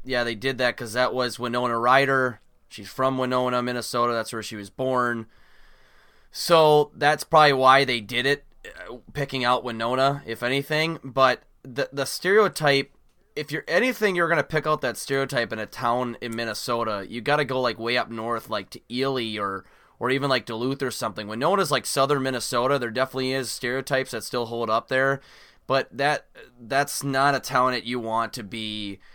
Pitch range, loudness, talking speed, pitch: 120-135 Hz, -24 LUFS, 190 wpm, 125 Hz